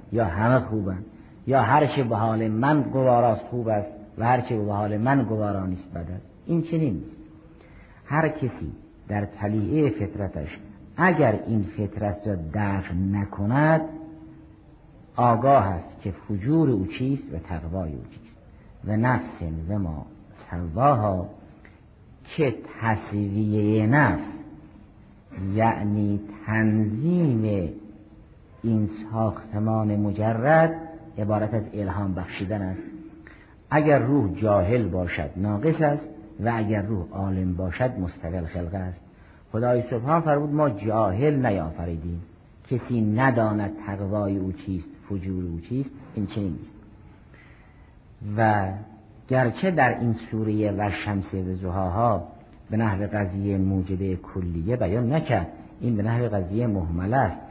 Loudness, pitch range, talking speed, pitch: -25 LUFS, 95-120 Hz, 120 wpm, 105 Hz